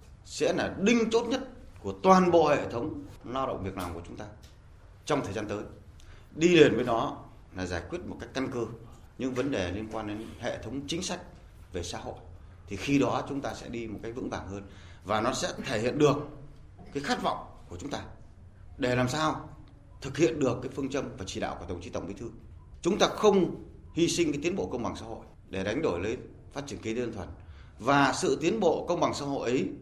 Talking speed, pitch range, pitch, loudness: 235 wpm, 95-140 Hz, 115 Hz, -29 LUFS